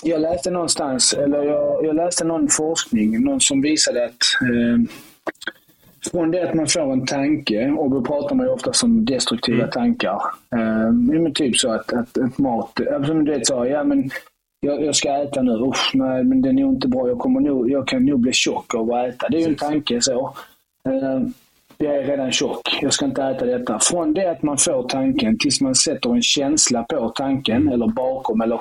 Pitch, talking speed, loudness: 160 Hz, 210 wpm, -19 LUFS